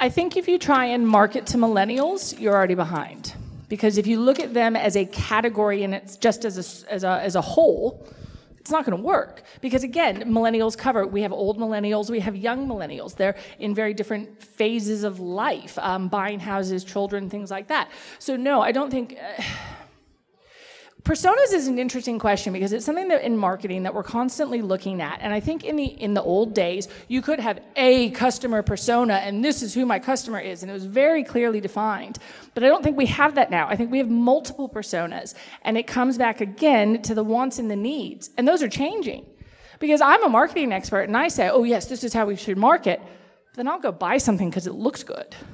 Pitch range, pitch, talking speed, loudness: 200-265 Hz, 225 Hz, 220 wpm, -22 LUFS